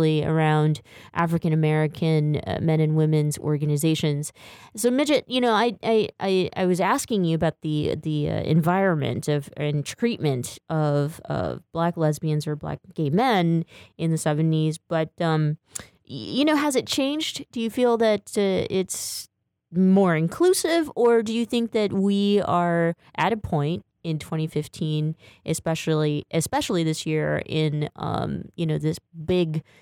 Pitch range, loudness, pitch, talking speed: 155-195 Hz, -24 LUFS, 160 Hz, 145 wpm